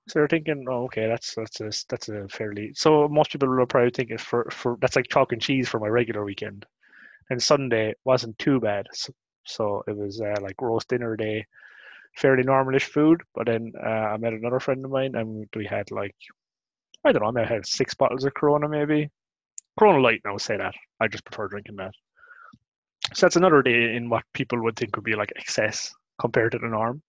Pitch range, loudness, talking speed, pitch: 110-135 Hz, -24 LUFS, 215 wpm, 120 Hz